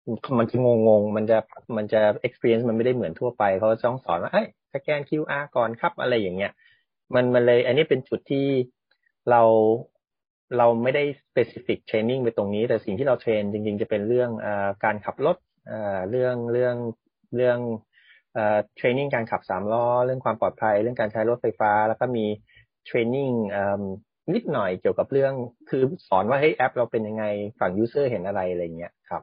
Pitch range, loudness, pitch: 105-125 Hz, -24 LUFS, 115 Hz